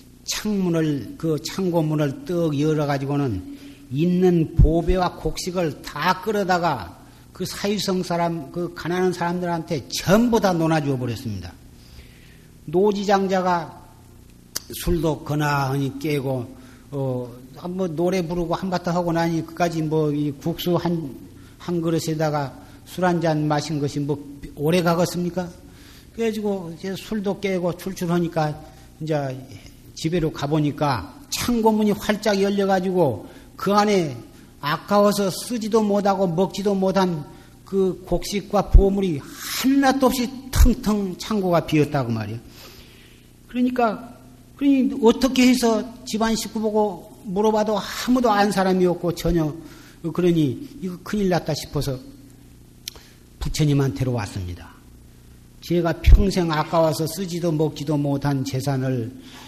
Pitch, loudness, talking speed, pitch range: 170 Hz, -22 LUFS, 265 characters per minute, 145-190 Hz